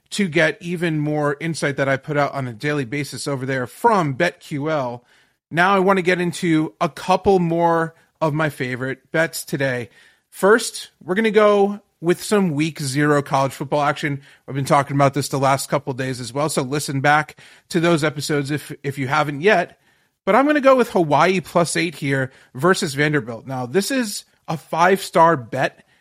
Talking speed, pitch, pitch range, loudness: 195 wpm, 155 Hz, 140-175 Hz, -19 LUFS